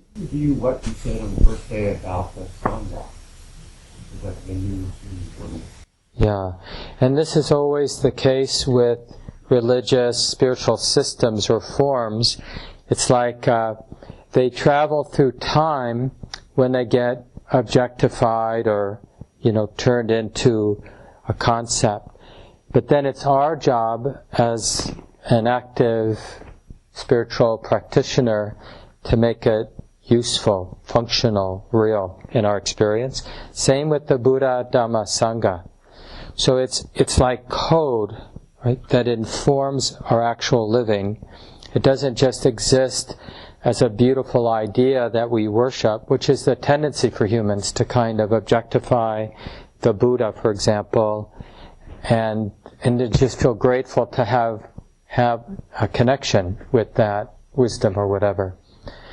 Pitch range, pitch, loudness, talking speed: 105-130 Hz, 120 Hz, -20 LUFS, 120 wpm